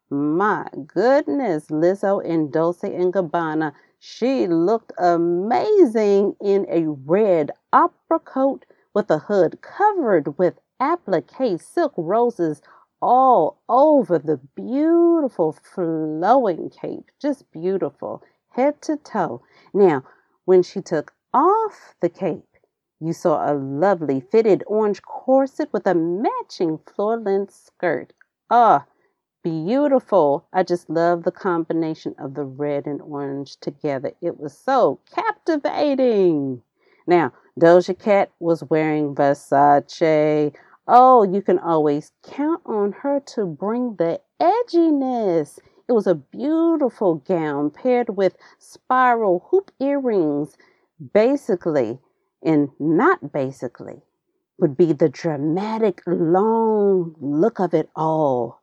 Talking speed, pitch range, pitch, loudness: 115 wpm, 160-255 Hz, 185 Hz, -20 LUFS